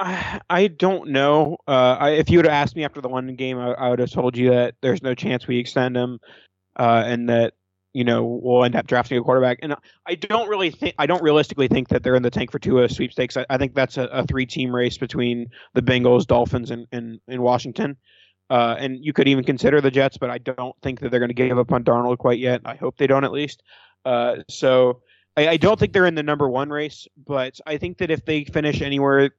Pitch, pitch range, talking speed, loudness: 130 Hz, 125-145 Hz, 245 wpm, -20 LUFS